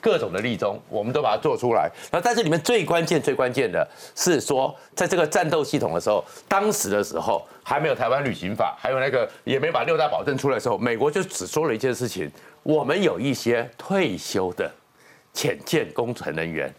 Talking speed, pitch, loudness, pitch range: 320 characters per minute, 155 Hz, -24 LUFS, 120-195 Hz